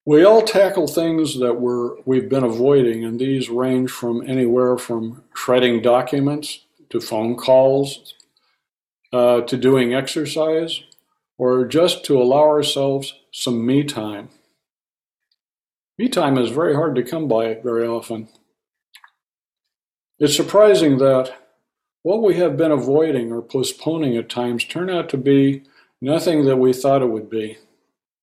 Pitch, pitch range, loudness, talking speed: 130 Hz, 120-150 Hz, -18 LUFS, 140 wpm